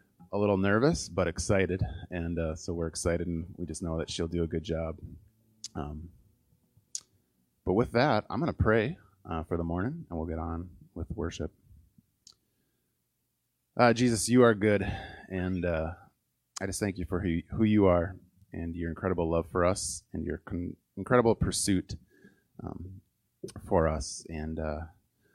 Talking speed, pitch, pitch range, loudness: 165 wpm, 90 Hz, 85-100 Hz, -30 LUFS